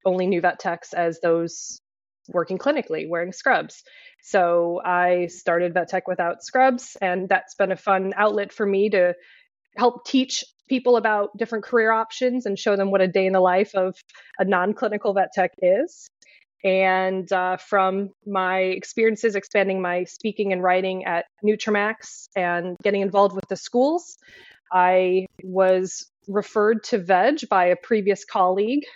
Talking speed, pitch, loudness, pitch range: 155 wpm, 195 Hz, -22 LUFS, 185-220 Hz